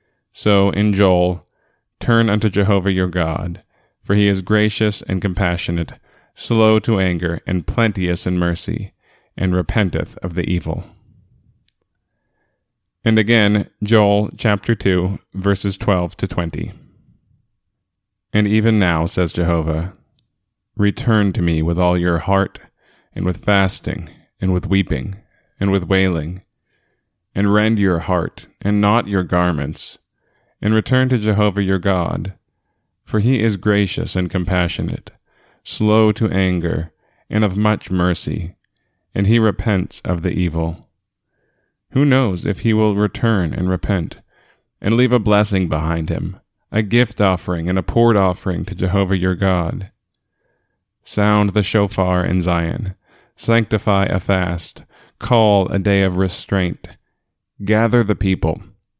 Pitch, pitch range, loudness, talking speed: 100 Hz, 90-105 Hz, -18 LUFS, 130 wpm